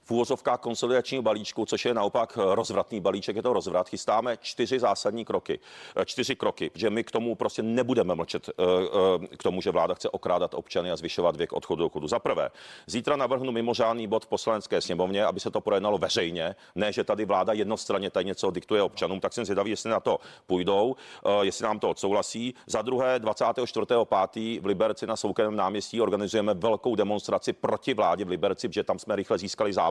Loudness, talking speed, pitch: -28 LUFS, 185 wpm, 125 Hz